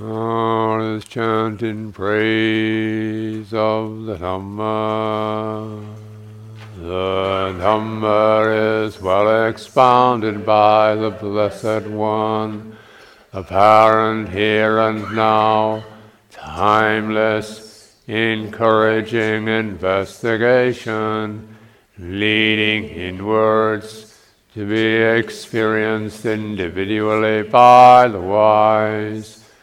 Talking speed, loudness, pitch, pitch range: 65 wpm, -16 LUFS, 110 Hz, 105-110 Hz